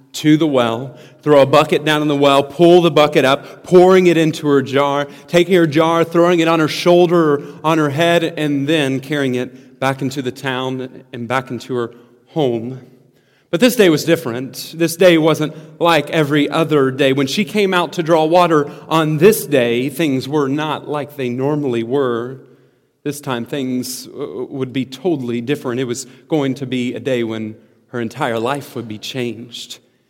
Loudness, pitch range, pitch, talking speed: -15 LUFS, 130-160 Hz, 140 Hz, 185 wpm